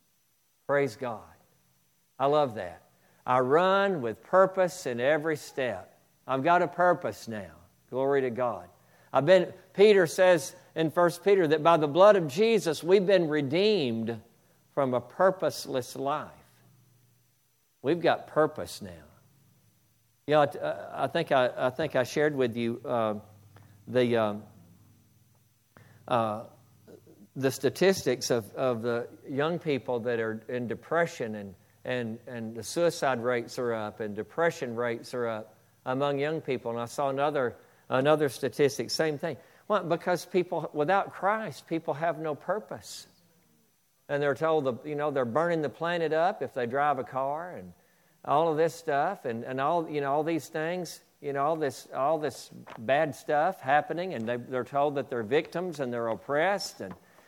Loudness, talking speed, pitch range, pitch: -28 LUFS, 160 wpm, 115-165 Hz, 140 Hz